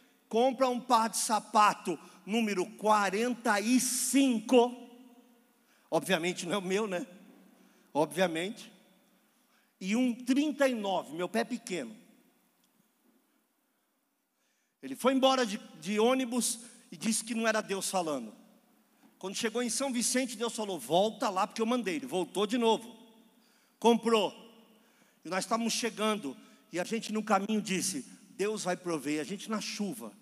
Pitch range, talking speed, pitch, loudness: 205-245 Hz, 135 wpm, 230 Hz, -31 LUFS